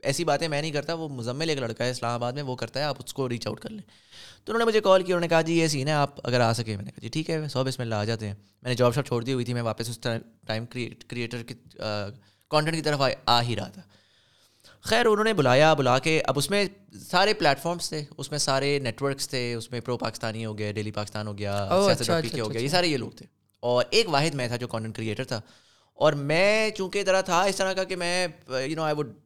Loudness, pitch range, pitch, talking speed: -26 LUFS, 115-160 Hz, 135 Hz, 270 wpm